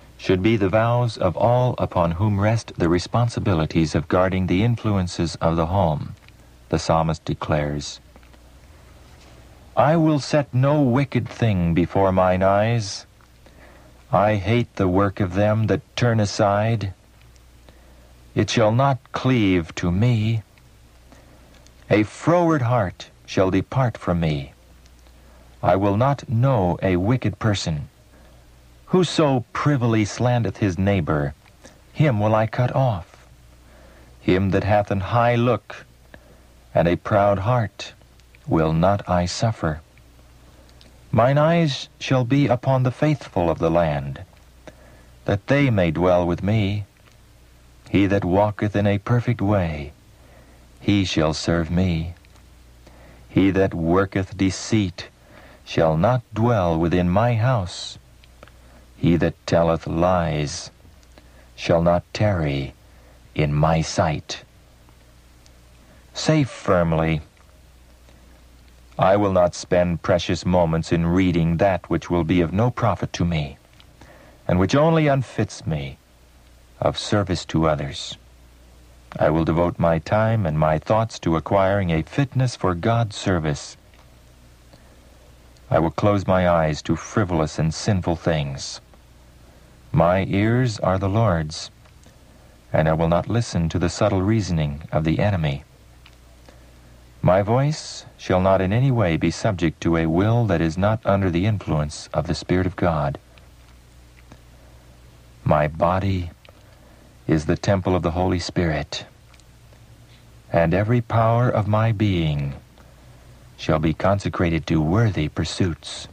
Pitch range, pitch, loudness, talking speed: 60-105 Hz, 85 Hz, -21 LUFS, 125 wpm